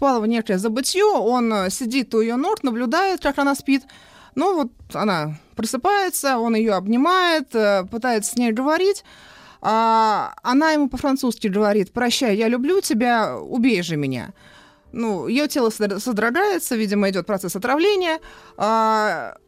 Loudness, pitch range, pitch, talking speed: -20 LUFS, 215-280 Hz, 240 Hz, 135 wpm